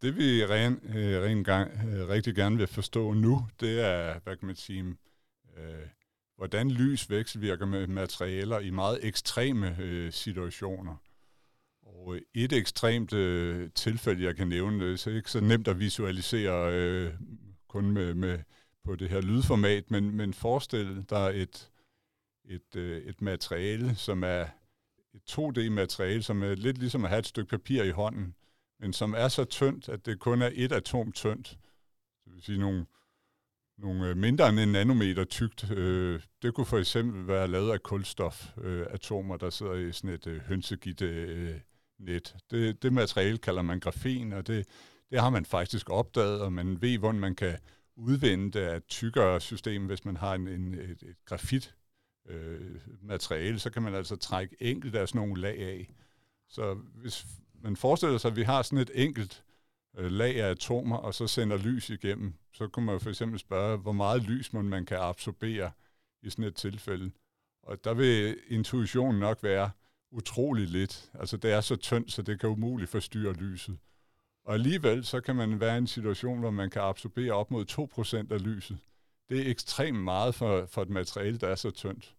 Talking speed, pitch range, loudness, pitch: 175 wpm, 95-115 Hz, -31 LUFS, 105 Hz